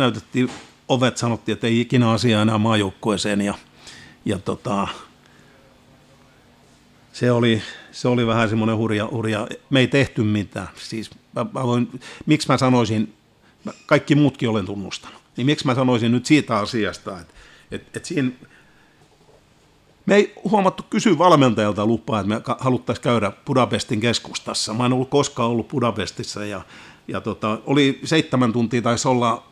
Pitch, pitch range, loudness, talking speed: 120 Hz, 110-130 Hz, -20 LUFS, 150 wpm